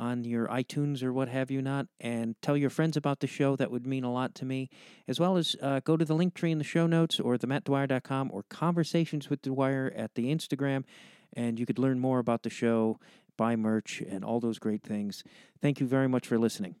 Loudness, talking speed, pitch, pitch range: -30 LUFS, 230 wpm, 135 Hz, 120-145 Hz